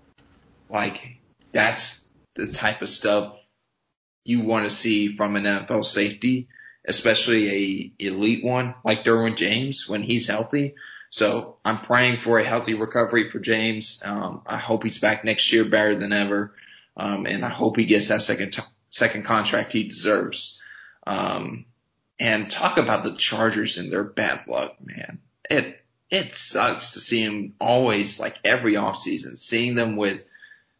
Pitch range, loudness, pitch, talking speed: 105-115 Hz, -22 LUFS, 110 Hz, 155 wpm